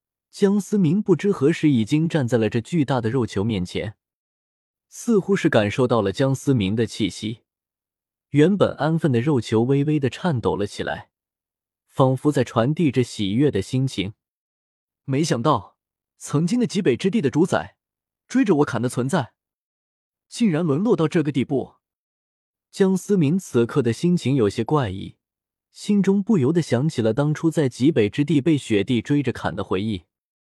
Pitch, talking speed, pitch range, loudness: 135 Hz, 245 characters per minute, 110-165 Hz, -21 LUFS